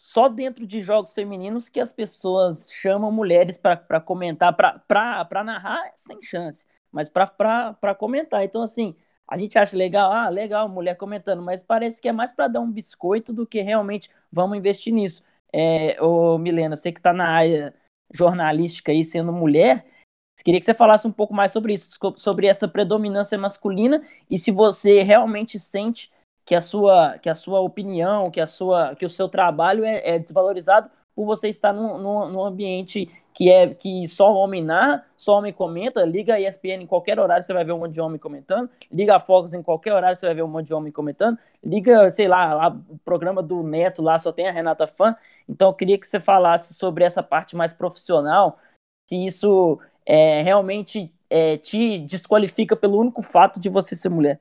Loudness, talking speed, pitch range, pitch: -20 LUFS, 195 wpm, 175-210 Hz, 195 Hz